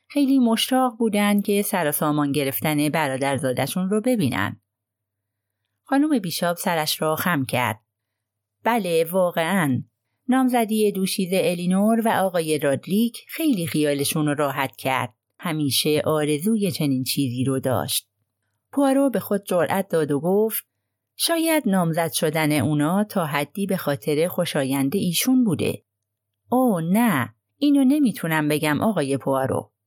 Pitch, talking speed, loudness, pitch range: 160 Hz, 120 wpm, -22 LUFS, 135-205 Hz